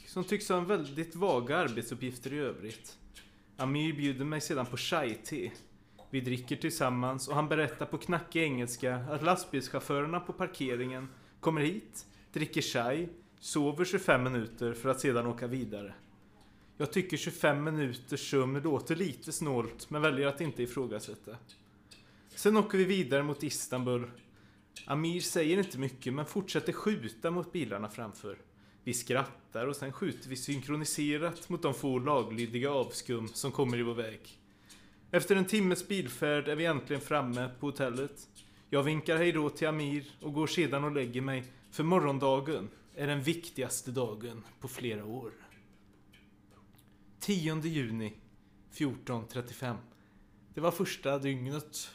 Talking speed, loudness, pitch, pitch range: 140 wpm, -34 LUFS, 135 Hz, 120-155 Hz